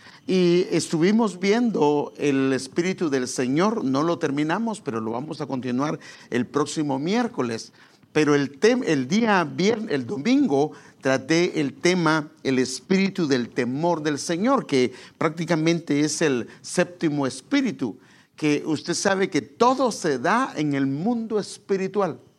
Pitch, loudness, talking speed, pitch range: 160 Hz, -23 LUFS, 140 wpm, 140-195 Hz